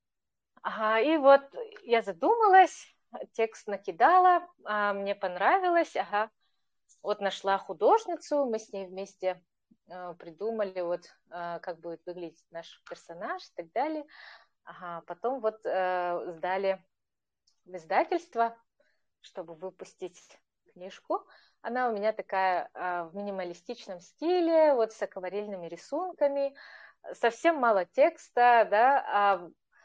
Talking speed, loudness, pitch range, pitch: 105 wpm, -28 LUFS, 180-280 Hz, 205 Hz